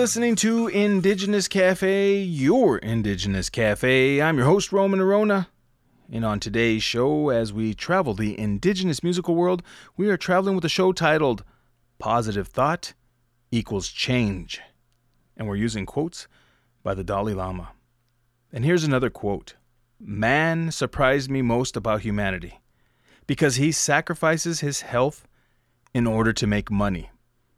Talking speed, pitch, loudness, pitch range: 135 wpm, 125 Hz, -23 LUFS, 110-170 Hz